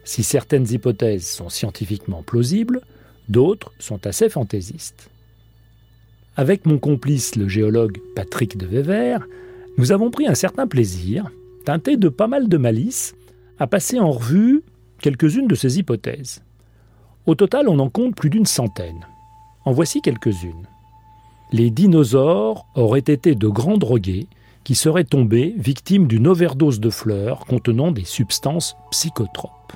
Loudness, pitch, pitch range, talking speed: -18 LUFS, 125 Hz, 110-155 Hz, 135 wpm